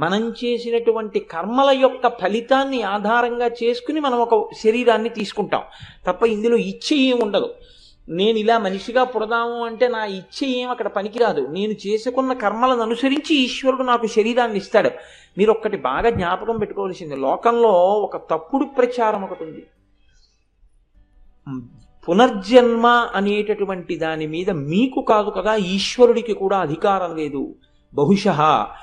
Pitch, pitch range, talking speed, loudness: 220 Hz, 190-240 Hz, 120 wpm, -19 LUFS